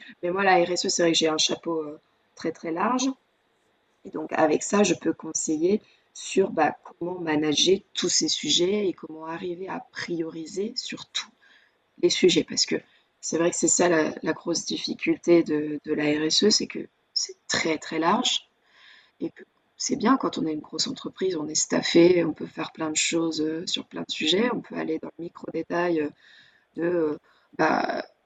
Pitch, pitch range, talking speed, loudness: 170 Hz, 160-205 Hz, 185 wpm, -25 LUFS